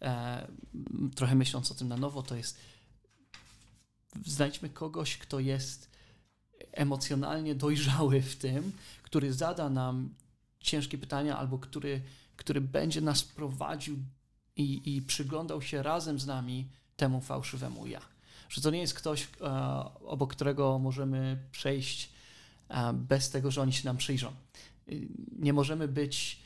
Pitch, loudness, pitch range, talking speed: 135 Hz, -34 LUFS, 125-145 Hz, 135 wpm